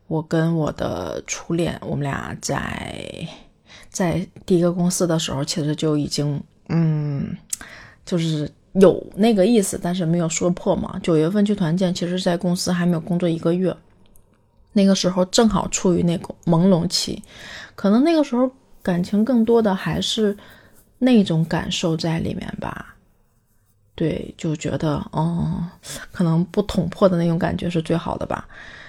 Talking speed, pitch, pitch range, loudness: 235 characters per minute, 175 Hz, 160-195 Hz, -21 LUFS